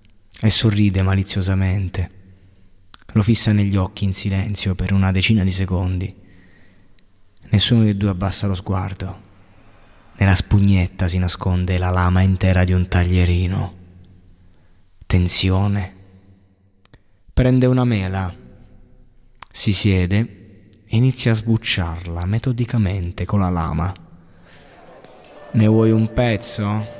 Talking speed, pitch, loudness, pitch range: 105 wpm, 95 Hz, -17 LUFS, 90-105 Hz